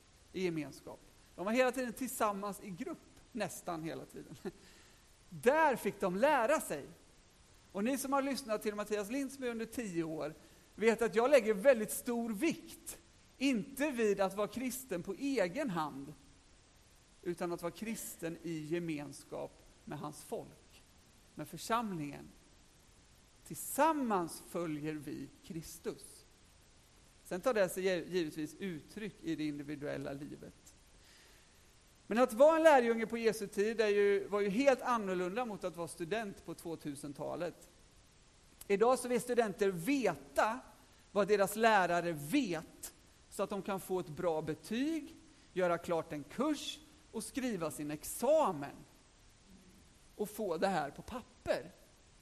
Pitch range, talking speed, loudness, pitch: 165-240 Hz, 135 wpm, -35 LUFS, 200 Hz